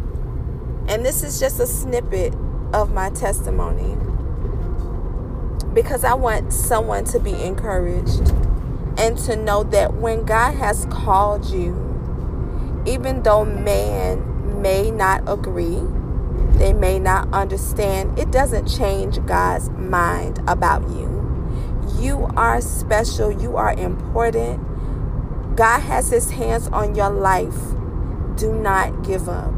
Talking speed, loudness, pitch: 120 wpm, -20 LUFS, 90 Hz